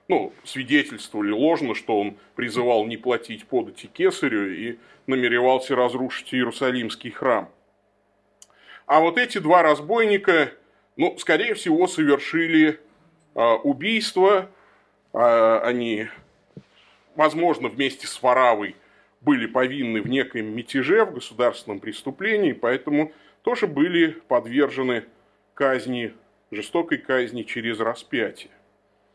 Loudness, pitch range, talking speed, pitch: -22 LUFS, 120-195 Hz, 95 wpm, 135 Hz